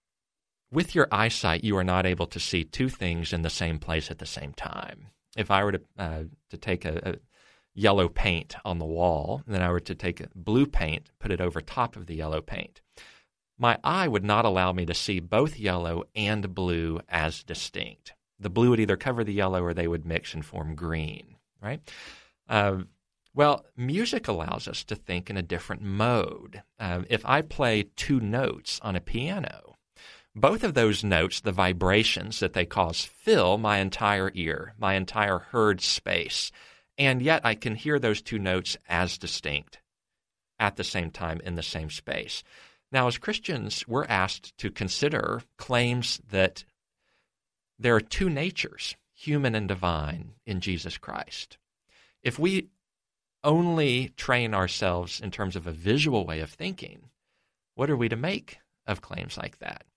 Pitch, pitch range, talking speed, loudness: 100 Hz, 90-115 Hz, 175 wpm, -27 LUFS